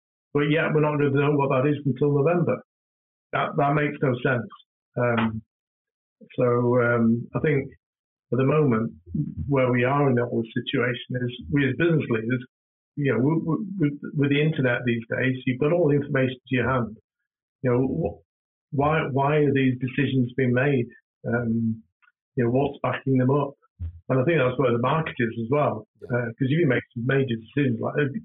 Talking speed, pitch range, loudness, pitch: 195 wpm, 120-145 Hz, -24 LUFS, 130 Hz